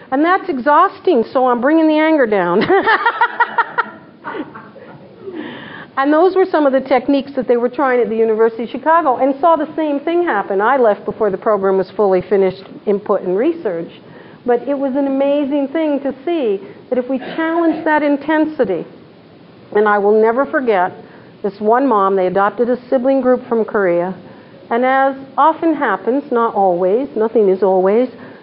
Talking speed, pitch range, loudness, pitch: 170 wpm, 215-310 Hz, -15 LUFS, 265 Hz